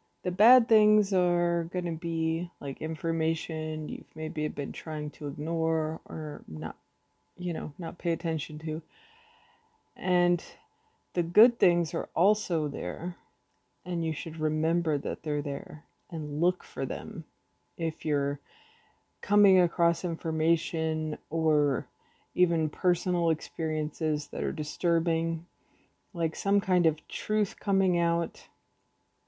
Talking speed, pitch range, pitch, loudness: 125 wpm, 155-180 Hz, 165 Hz, -29 LUFS